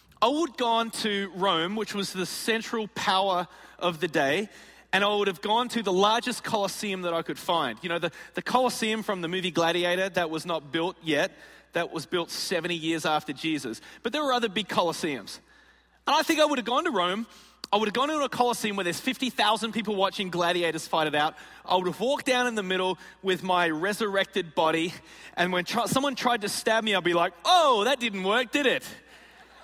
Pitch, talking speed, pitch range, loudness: 195 Hz, 220 wpm, 175-235 Hz, -26 LUFS